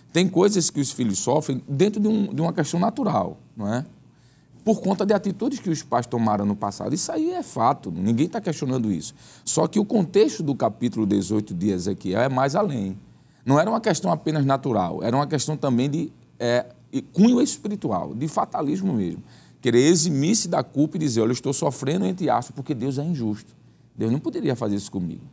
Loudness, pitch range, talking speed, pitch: -23 LUFS, 120-185 Hz, 195 wpm, 145 Hz